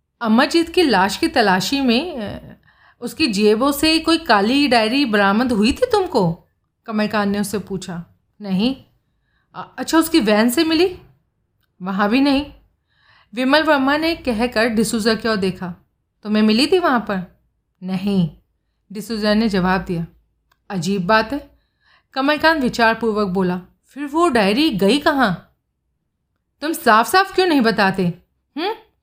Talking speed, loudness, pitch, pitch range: 135 wpm, -17 LUFS, 225 Hz, 195-290 Hz